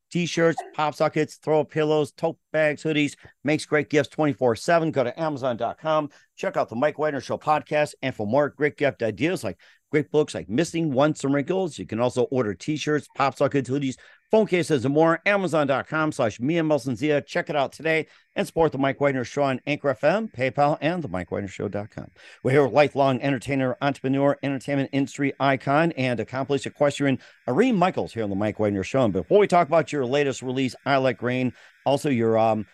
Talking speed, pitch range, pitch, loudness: 200 wpm, 130-155 Hz, 140 Hz, -24 LUFS